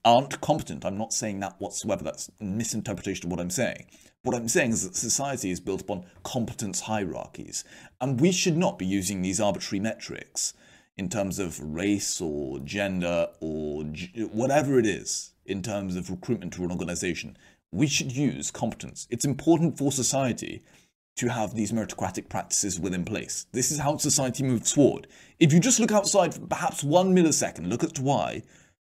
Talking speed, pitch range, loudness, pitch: 175 wpm, 95-140 Hz, -27 LUFS, 110 Hz